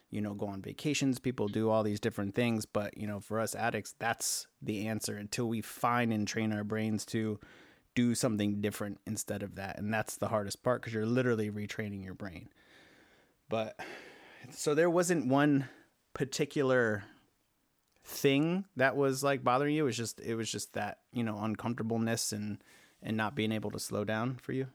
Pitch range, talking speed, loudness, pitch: 105-130 Hz, 185 wpm, -33 LUFS, 110 Hz